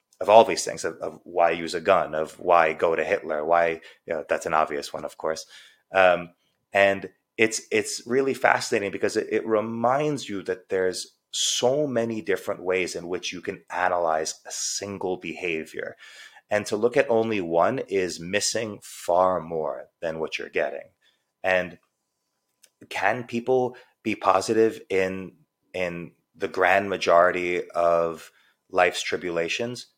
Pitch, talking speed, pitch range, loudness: 95 Hz, 150 wpm, 85-110 Hz, -24 LUFS